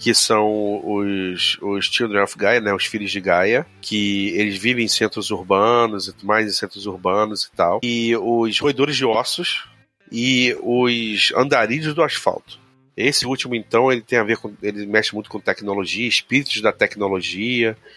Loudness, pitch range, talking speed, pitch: -19 LUFS, 100-120 Hz, 170 wpm, 110 Hz